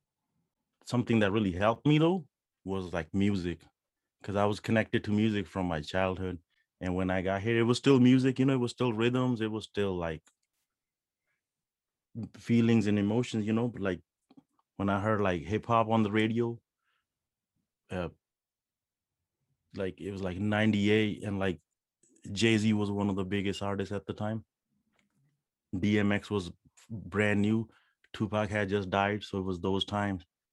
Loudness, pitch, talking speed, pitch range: -30 LUFS, 105 Hz, 165 wpm, 95-115 Hz